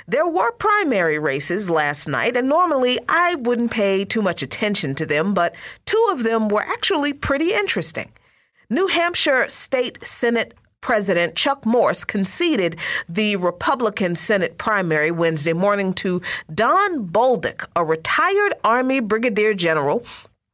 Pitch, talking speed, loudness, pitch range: 215 Hz, 135 wpm, -19 LUFS, 175-275 Hz